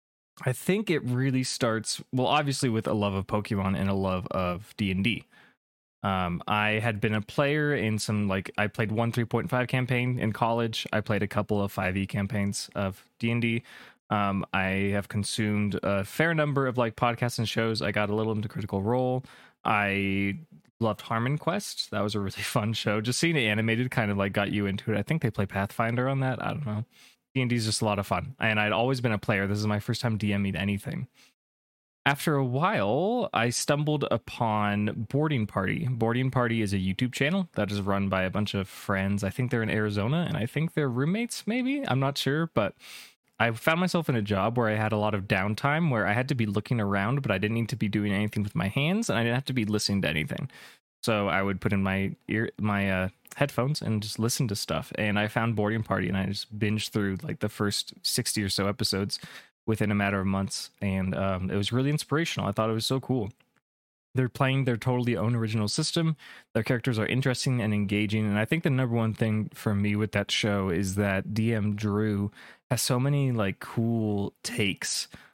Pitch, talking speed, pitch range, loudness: 110 Hz, 215 wpm, 100-125 Hz, -28 LUFS